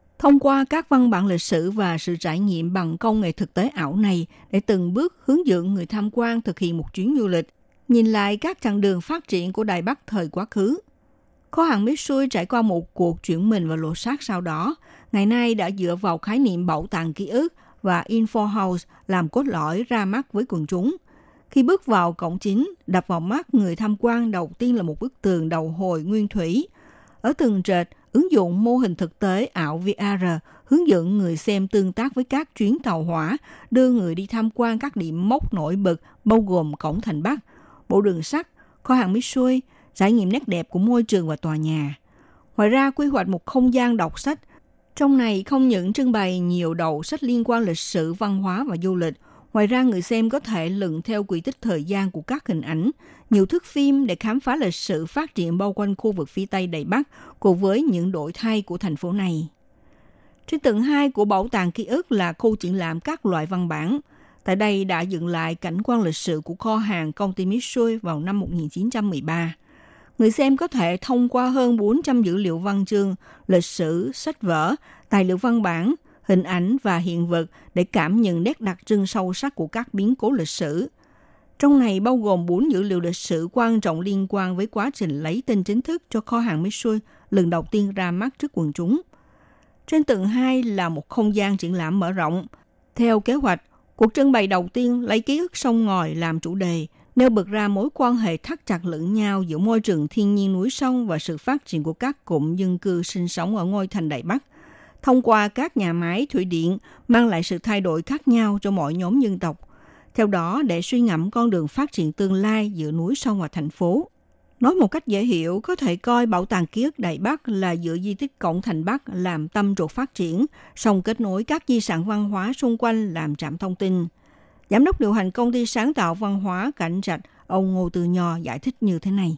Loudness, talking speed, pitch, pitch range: -22 LUFS, 225 wpm, 205 Hz, 175-240 Hz